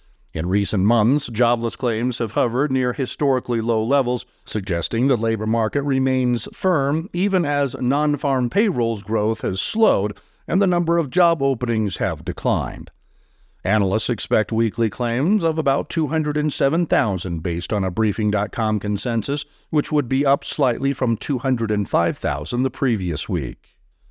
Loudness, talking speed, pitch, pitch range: -21 LUFS, 135 wpm, 125 Hz, 110-140 Hz